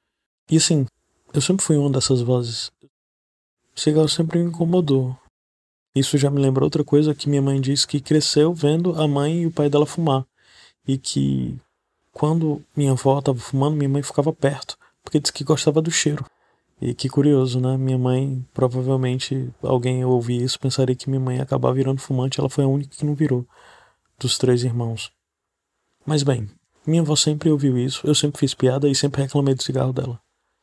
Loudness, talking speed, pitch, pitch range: -20 LUFS, 185 wpm, 135 Hz, 130-150 Hz